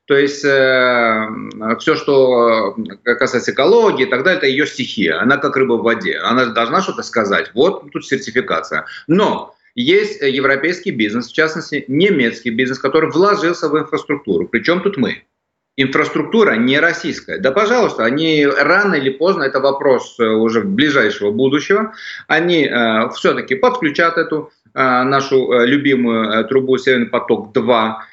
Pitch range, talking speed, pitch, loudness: 125-160 Hz, 140 wpm, 140 Hz, -15 LUFS